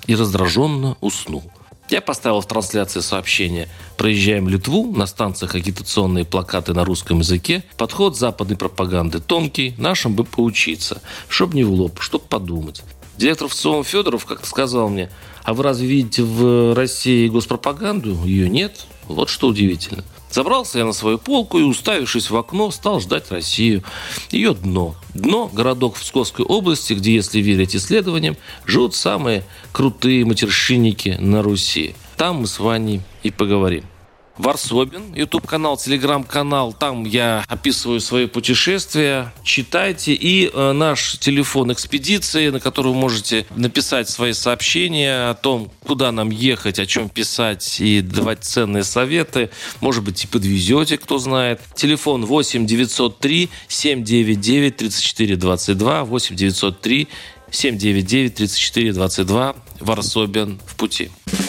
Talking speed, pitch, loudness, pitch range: 135 wpm, 115 Hz, -18 LUFS, 100-135 Hz